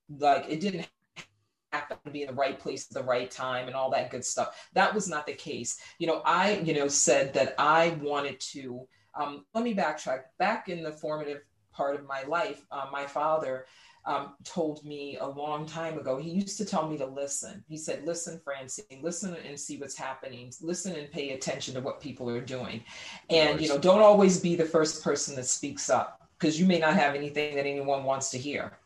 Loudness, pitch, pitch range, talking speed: -29 LUFS, 145 Hz, 135-165 Hz, 215 wpm